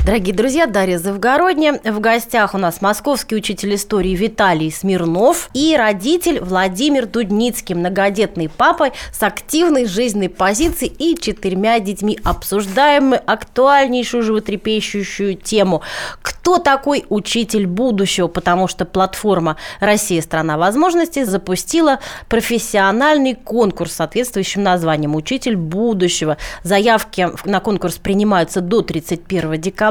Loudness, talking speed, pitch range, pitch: -16 LUFS, 110 wpm, 185-245 Hz, 210 Hz